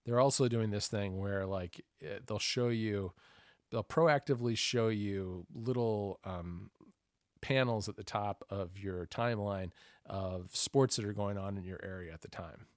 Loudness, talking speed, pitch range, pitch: -35 LUFS, 165 wpm, 95-120 Hz, 105 Hz